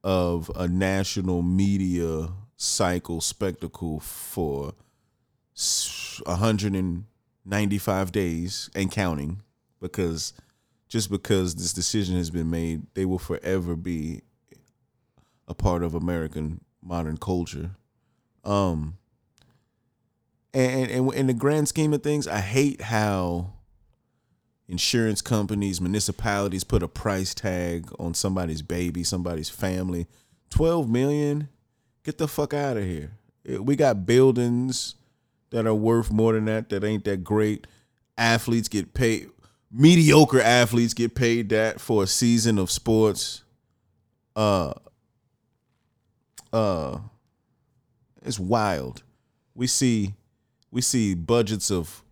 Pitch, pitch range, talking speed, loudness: 105 Hz, 90-120 Hz, 110 wpm, -24 LUFS